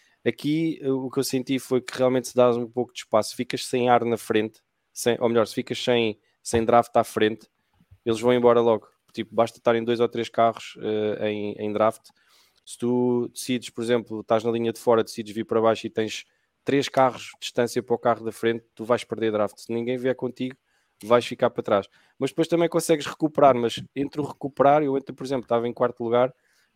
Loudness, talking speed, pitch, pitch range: -24 LUFS, 225 wpm, 120 Hz, 115-130 Hz